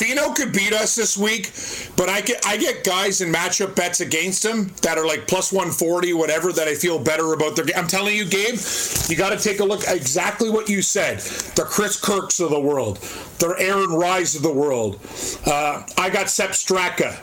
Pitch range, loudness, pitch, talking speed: 170-205 Hz, -20 LUFS, 185 Hz, 215 wpm